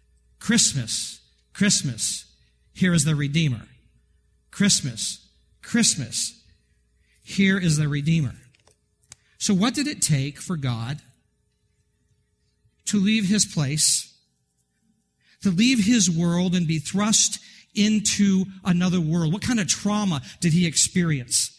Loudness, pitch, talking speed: -22 LUFS, 150 Hz, 110 wpm